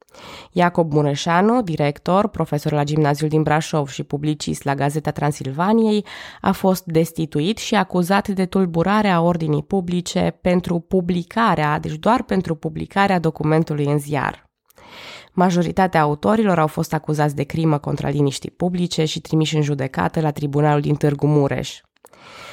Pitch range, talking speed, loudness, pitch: 150-185 Hz, 135 wpm, -19 LUFS, 160 Hz